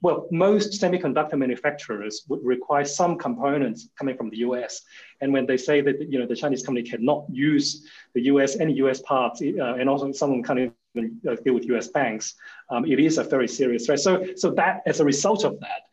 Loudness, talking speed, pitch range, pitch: -24 LUFS, 205 wpm, 125-150 Hz, 140 Hz